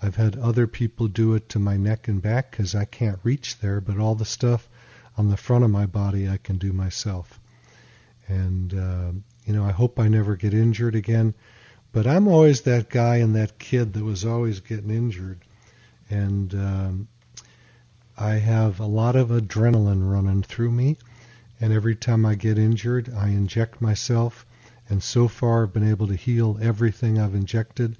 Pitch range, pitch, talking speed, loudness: 105-120 Hz, 110 Hz, 180 wpm, -23 LUFS